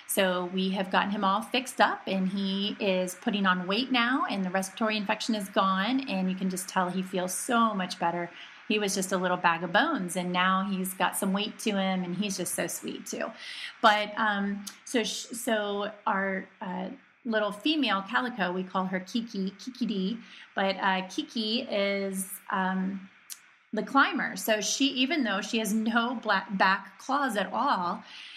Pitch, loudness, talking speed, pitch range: 200 Hz, -28 LUFS, 185 wpm, 190-225 Hz